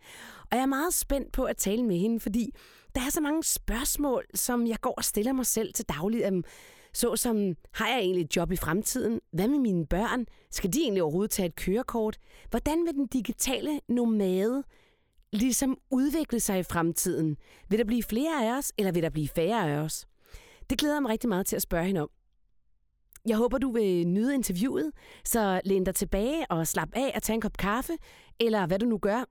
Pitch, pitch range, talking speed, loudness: 225 Hz, 185-260 Hz, 210 wpm, -29 LUFS